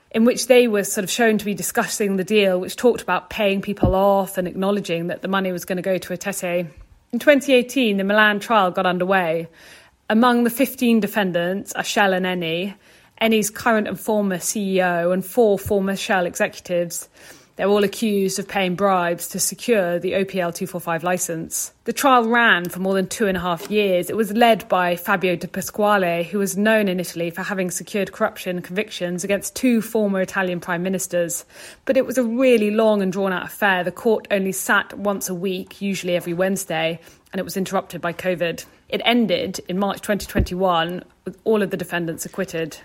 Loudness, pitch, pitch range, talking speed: -20 LUFS, 190 Hz, 180-210 Hz, 195 wpm